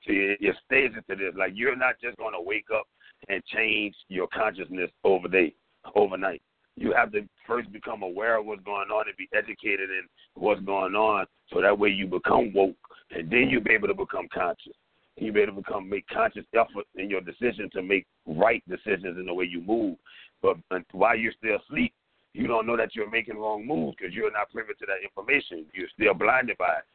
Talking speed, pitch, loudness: 205 wpm, 110 Hz, -27 LUFS